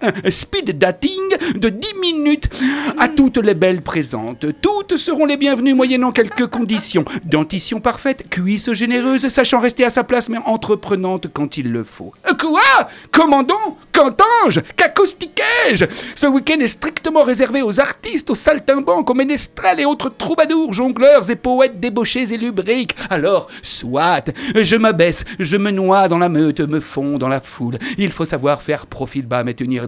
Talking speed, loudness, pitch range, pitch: 160 wpm, -16 LUFS, 185-285 Hz, 245 Hz